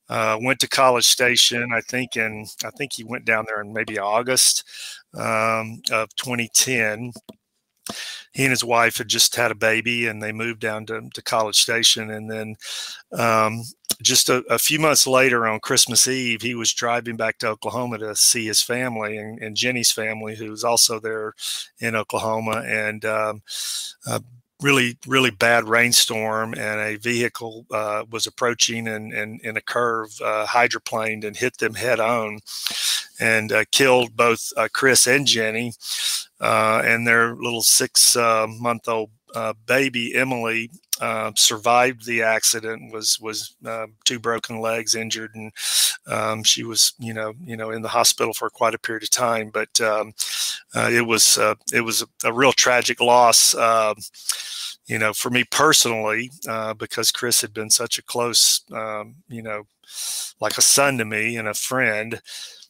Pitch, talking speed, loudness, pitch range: 115 Hz, 170 wpm, -19 LUFS, 110-120 Hz